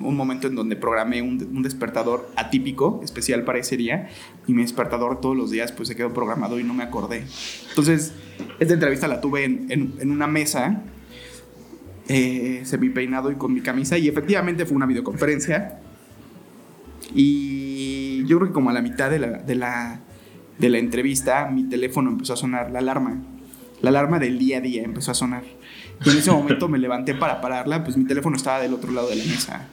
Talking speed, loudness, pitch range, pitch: 200 wpm, -22 LUFS, 125-145 Hz, 130 Hz